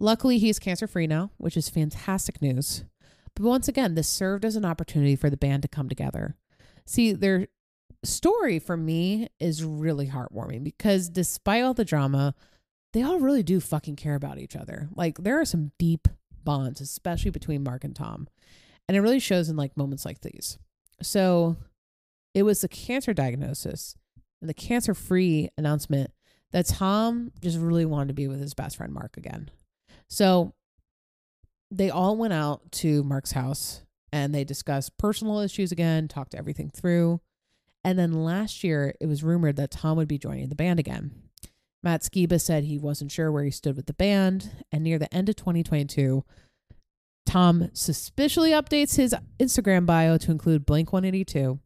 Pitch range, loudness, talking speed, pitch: 145-190 Hz, -26 LUFS, 170 wpm, 165 Hz